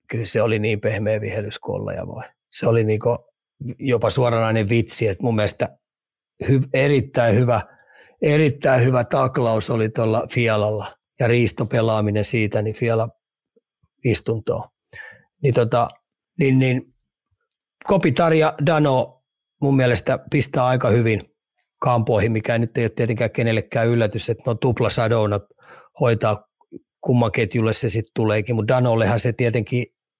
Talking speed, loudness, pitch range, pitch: 125 wpm, -20 LUFS, 110-130 Hz, 115 Hz